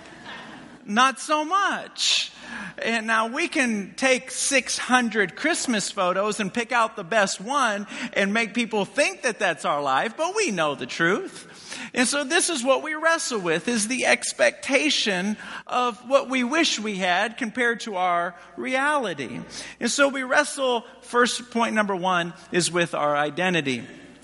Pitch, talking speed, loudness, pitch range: 240 Hz, 155 wpm, -23 LUFS, 205-275 Hz